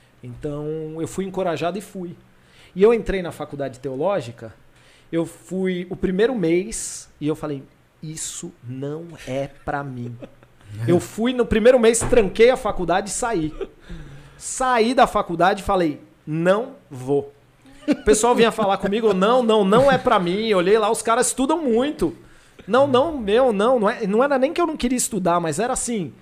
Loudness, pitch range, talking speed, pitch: -20 LUFS, 155-235 Hz, 175 wpm, 190 Hz